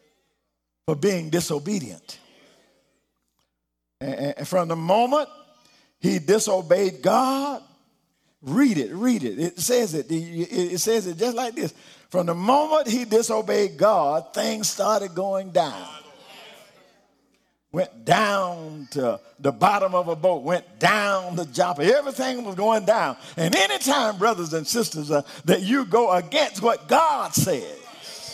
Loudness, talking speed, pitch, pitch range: -22 LUFS, 130 wpm, 190 Hz, 165-225 Hz